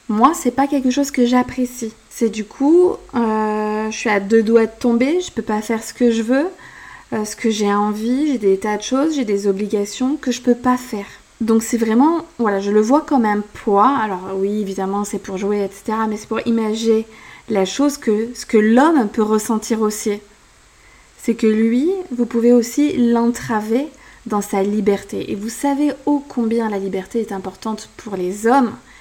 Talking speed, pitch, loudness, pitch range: 200 wpm, 225 Hz, -18 LUFS, 210-255 Hz